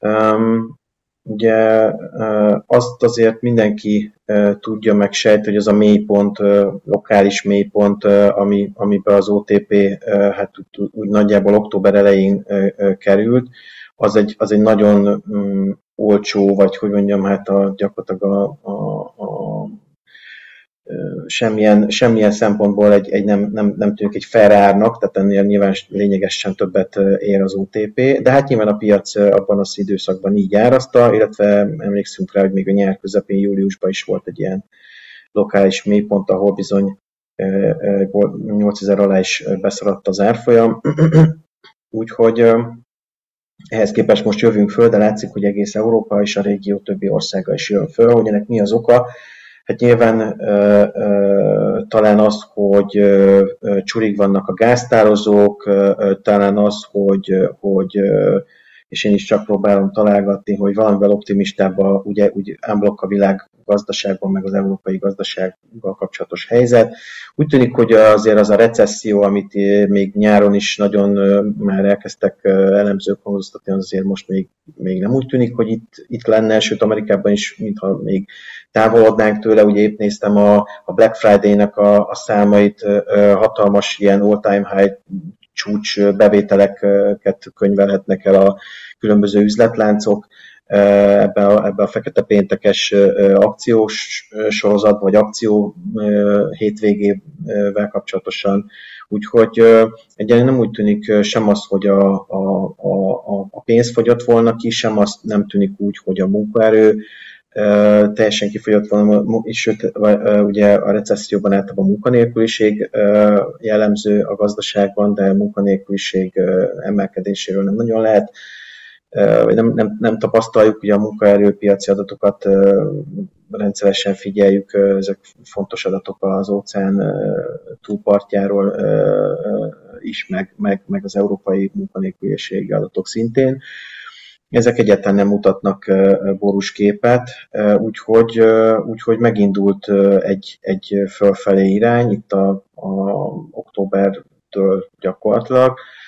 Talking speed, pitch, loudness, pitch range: 130 wpm, 100 Hz, -14 LUFS, 100-110 Hz